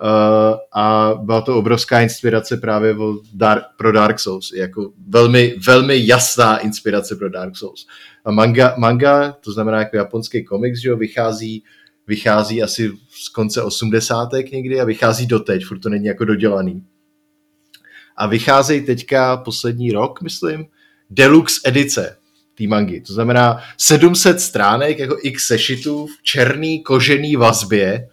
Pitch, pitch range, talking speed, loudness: 115 Hz, 110-130 Hz, 140 wpm, -15 LUFS